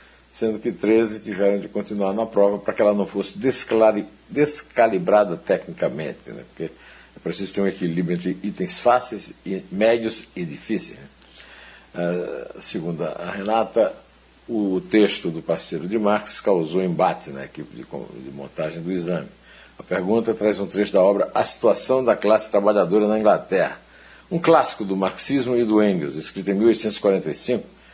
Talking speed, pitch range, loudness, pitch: 155 wpm, 95-110 Hz, -21 LUFS, 105 Hz